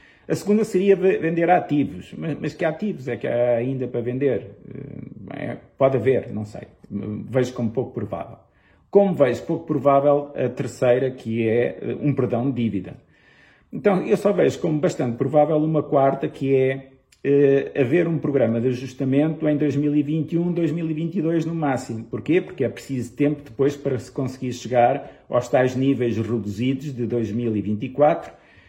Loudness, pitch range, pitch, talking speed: -22 LUFS, 120-155 Hz, 135 Hz, 155 wpm